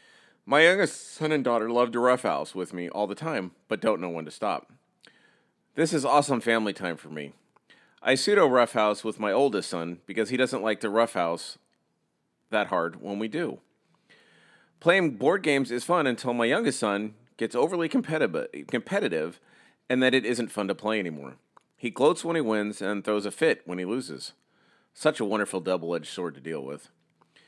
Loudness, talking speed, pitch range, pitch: -26 LUFS, 185 wpm, 100-130 Hz, 110 Hz